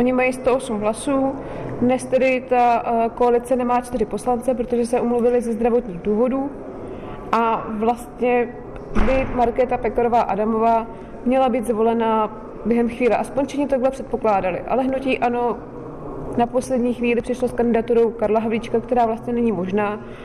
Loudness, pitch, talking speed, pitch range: -20 LUFS, 240 Hz, 140 wpm, 225-250 Hz